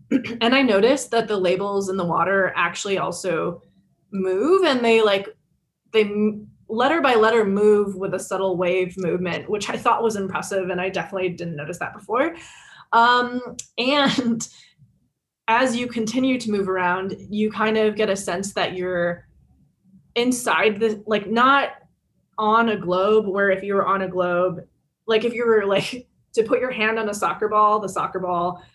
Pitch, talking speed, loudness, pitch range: 205 Hz, 175 wpm, -21 LUFS, 185-230 Hz